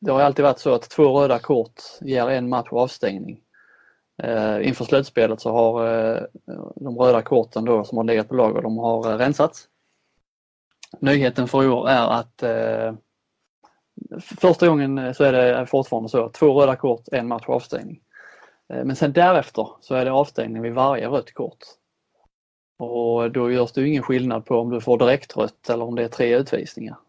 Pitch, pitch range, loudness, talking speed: 125 Hz, 115-135 Hz, -20 LUFS, 175 wpm